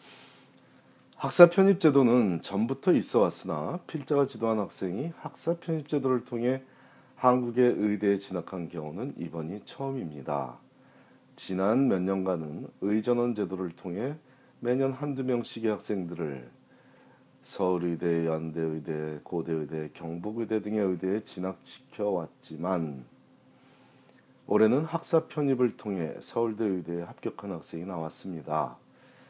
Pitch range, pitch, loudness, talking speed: 85-130 Hz, 105 Hz, -29 LUFS, 270 characters per minute